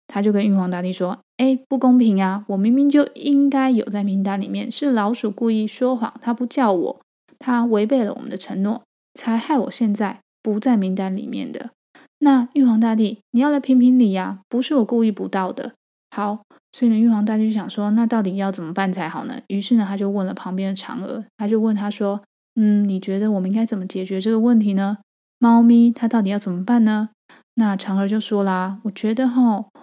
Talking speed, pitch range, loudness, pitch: 310 characters per minute, 200-245 Hz, -19 LUFS, 220 Hz